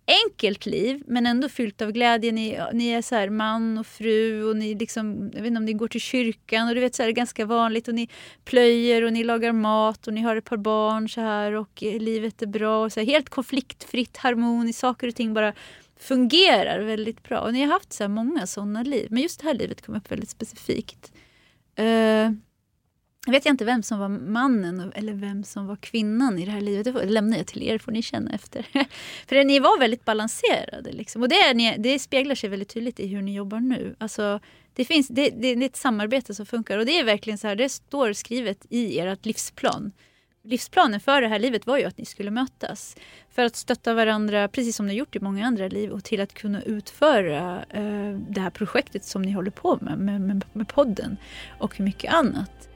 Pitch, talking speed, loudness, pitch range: 225 Hz, 225 wpm, -24 LUFS, 210-250 Hz